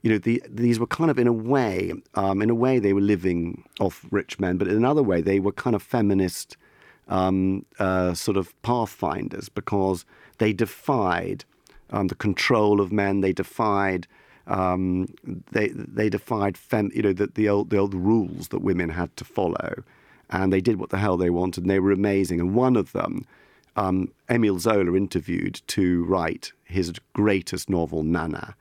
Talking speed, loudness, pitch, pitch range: 185 wpm, -24 LUFS, 100 Hz, 95-105 Hz